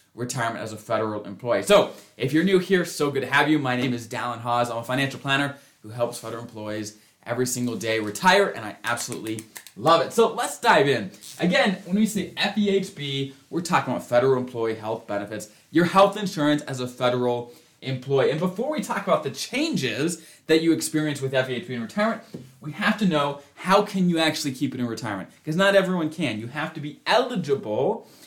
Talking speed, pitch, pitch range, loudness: 200 wpm, 135 Hz, 120-170 Hz, -24 LUFS